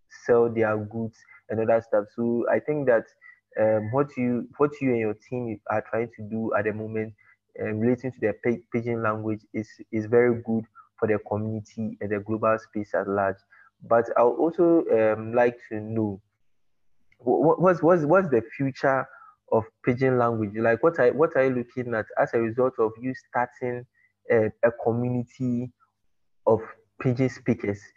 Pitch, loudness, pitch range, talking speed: 115 Hz, -25 LUFS, 110-125 Hz, 180 wpm